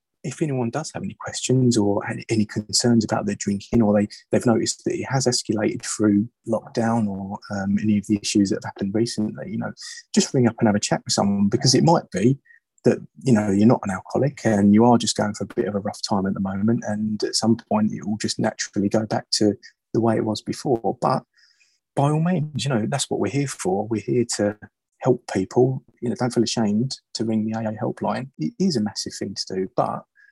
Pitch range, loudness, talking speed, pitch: 105-125 Hz, -22 LUFS, 240 wpm, 115 Hz